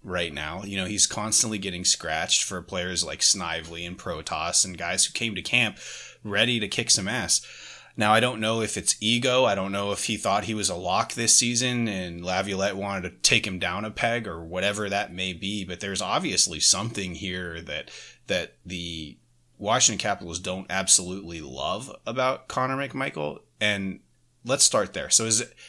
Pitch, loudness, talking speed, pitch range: 100 Hz, -24 LUFS, 190 wpm, 90-110 Hz